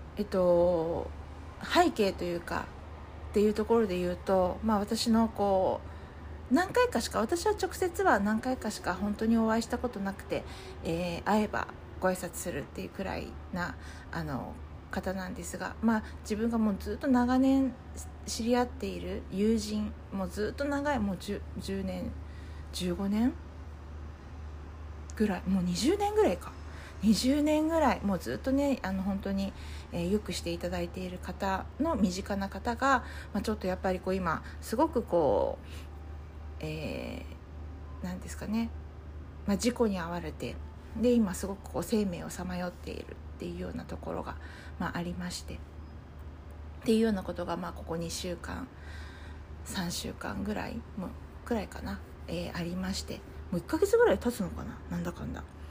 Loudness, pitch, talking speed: -32 LUFS, 180 Hz, 300 characters per minute